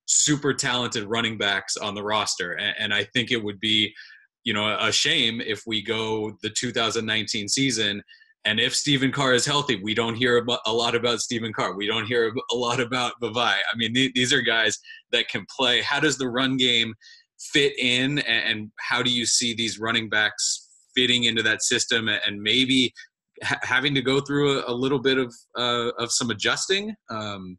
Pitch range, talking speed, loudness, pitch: 110-130 Hz, 185 wpm, -22 LUFS, 120 Hz